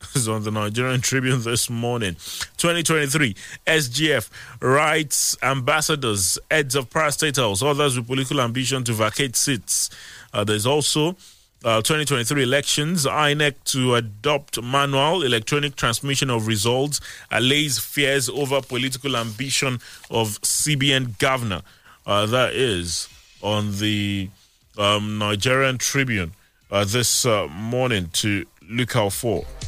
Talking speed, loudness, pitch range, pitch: 125 wpm, -21 LUFS, 110-140 Hz, 130 Hz